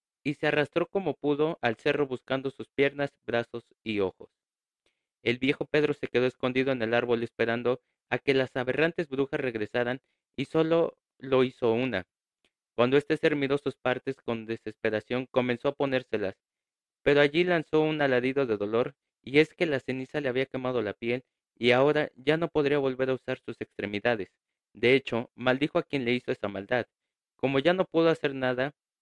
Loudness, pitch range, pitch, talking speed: -28 LUFS, 120-145 Hz, 130 Hz, 180 wpm